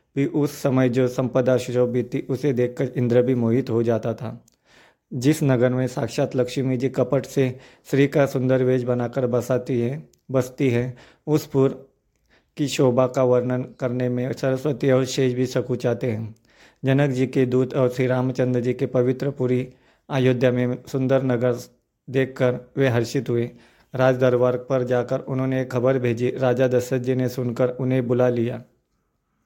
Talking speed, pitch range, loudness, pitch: 165 wpm, 125-135 Hz, -22 LUFS, 130 Hz